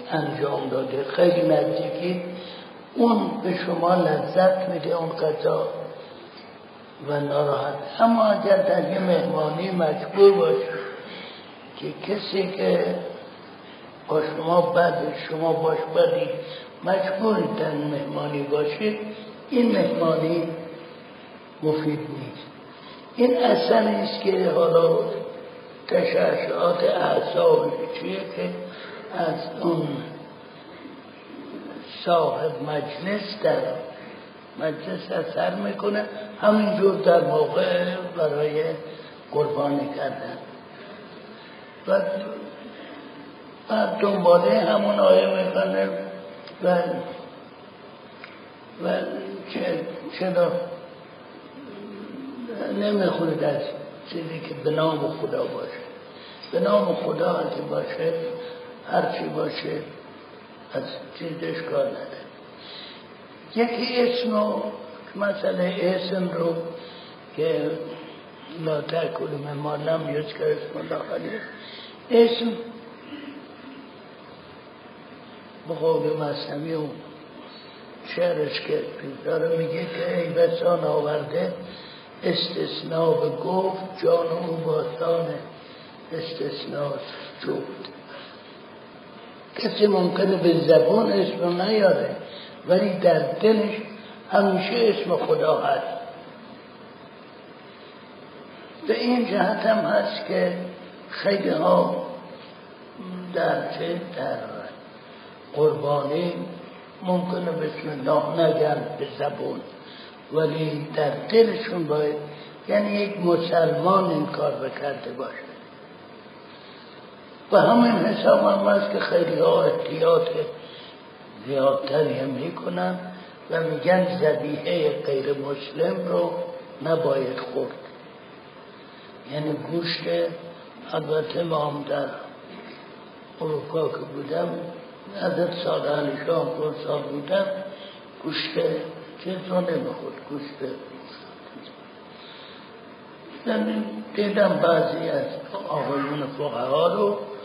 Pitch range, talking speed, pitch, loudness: 160-235 Hz, 85 wpm, 185 Hz, -24 LUFS